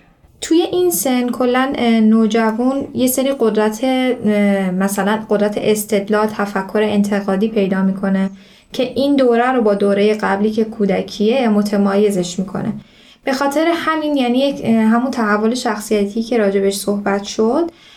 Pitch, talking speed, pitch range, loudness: 220 Hz, 125 wpm, 205-250 Hz, -16 LUFS